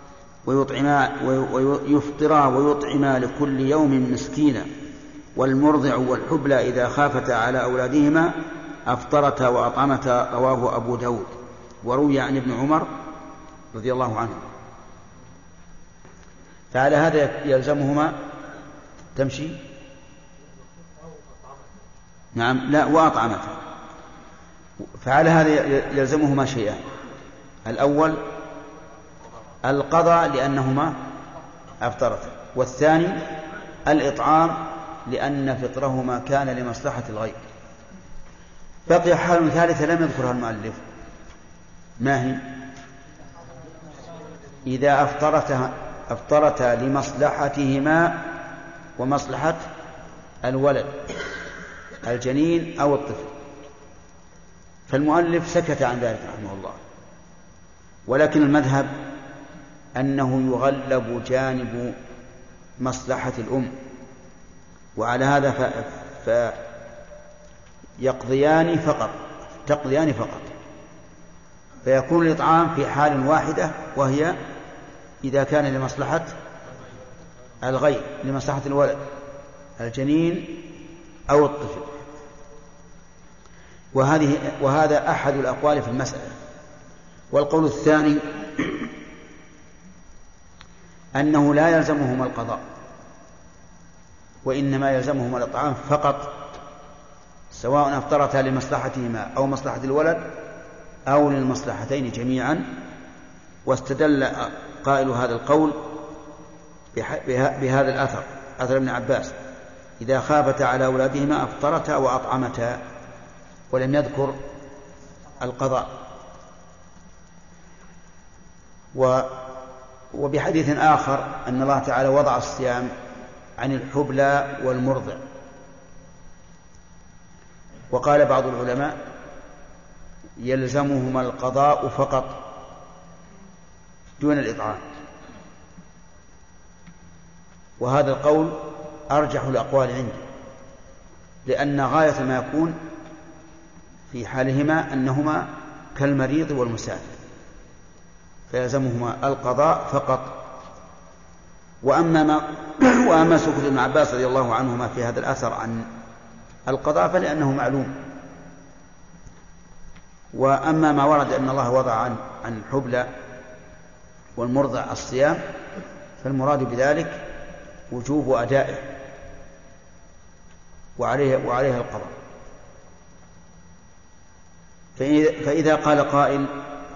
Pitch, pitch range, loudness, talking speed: 140 Hz, 130-150 Hz, -22 LUFS, 75 wpm